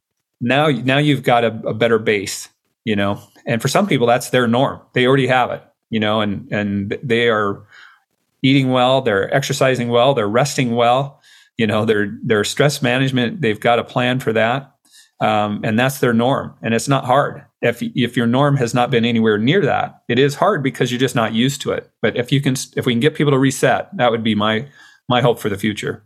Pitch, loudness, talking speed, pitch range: 125 Hz, -17 LUFS, 220 wpm, 115-135 Hz